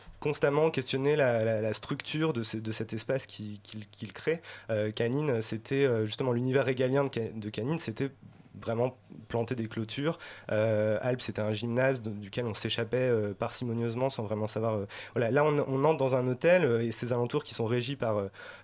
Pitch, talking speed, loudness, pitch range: 115 Hz, 180 wpm, -30 LUFS, 110-135 Hz